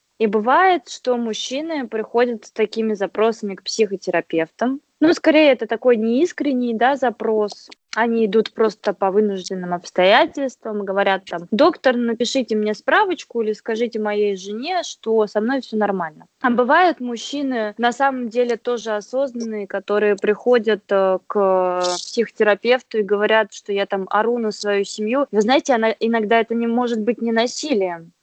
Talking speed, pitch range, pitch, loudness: 145 wpm, 205-250 Hz, 225 Hz, -19 LUFS